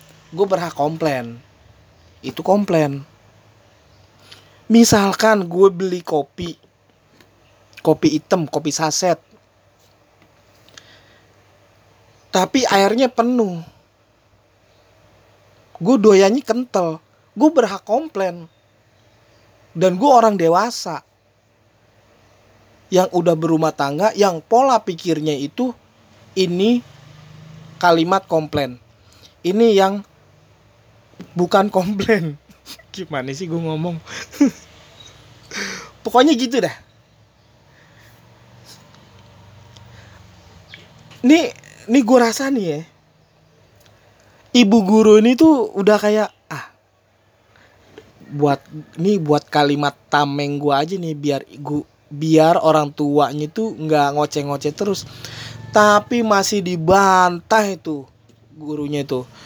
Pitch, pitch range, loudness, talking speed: 150 Hz, 115-195 Hz, -17 LUFS, 85 wpm